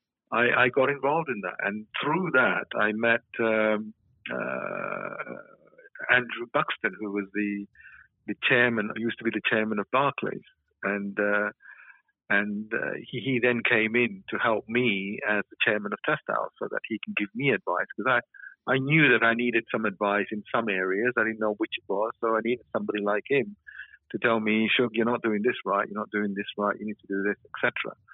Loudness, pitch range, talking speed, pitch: -26 LUFS, 105-120 Hz, 205 wpm, 110 Hz